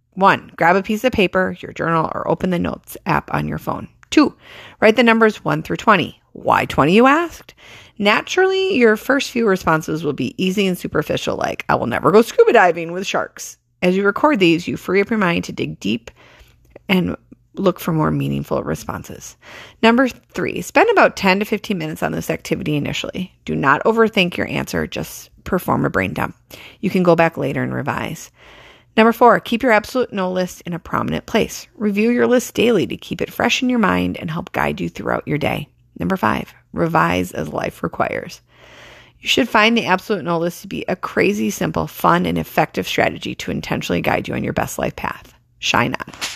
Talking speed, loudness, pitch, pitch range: 200 wpm, -18 LUFS, 185 Hz, 155-225 Hz